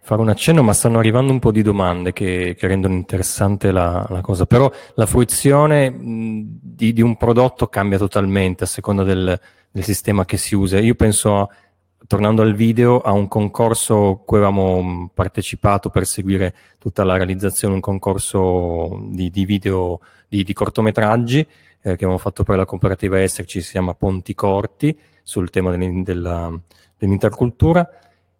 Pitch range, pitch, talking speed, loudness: 95-110 Hz, 100 Hz, 160 wpm, -17 LUFS